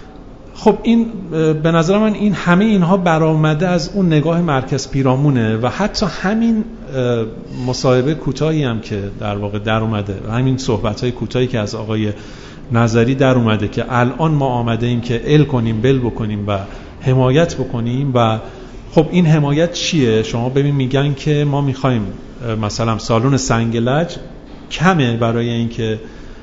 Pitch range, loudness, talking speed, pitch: 115-155 Hz, -16 LUFS, 150 wpm, 130 Hz